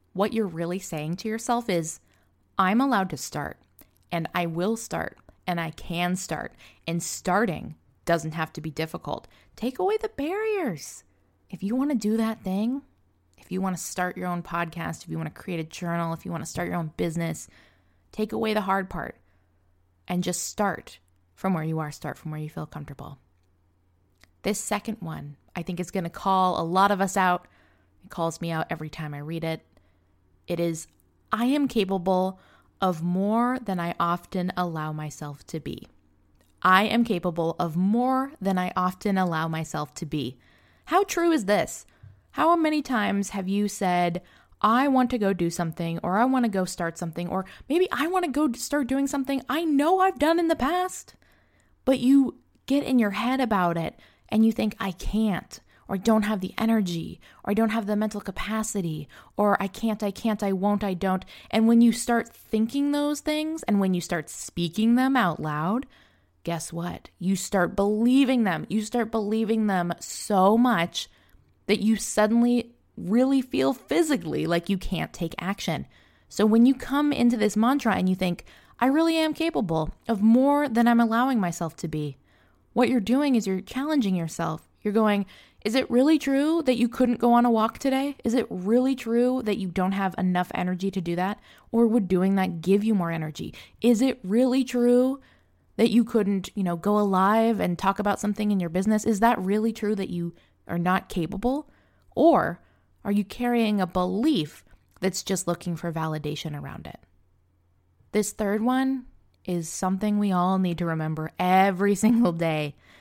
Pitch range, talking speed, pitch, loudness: 170-235 Hz, 190 wpm, 195 Hz, -25 LUFS